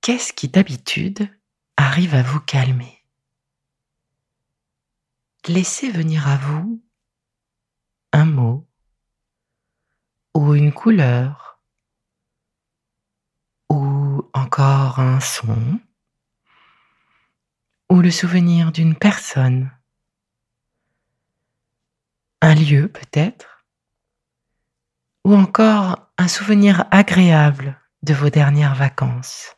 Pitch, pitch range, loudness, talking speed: 145 Hz, 130-175 Hz, -16 LUFS, 75 wpm